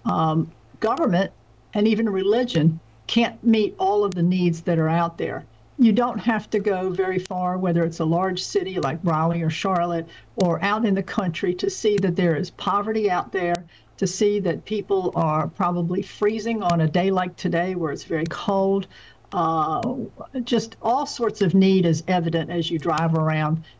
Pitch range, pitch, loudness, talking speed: 165-210 Hz, 185 Hz, -23 LUFS, 180 wpm